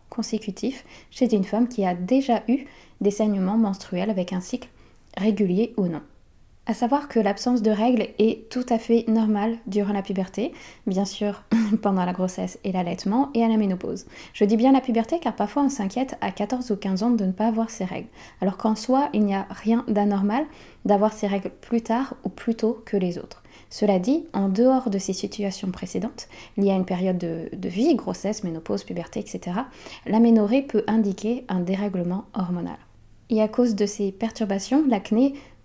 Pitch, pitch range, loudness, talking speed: 215 Hz, 195-230 Hz, -24 LUFS, 190 wpm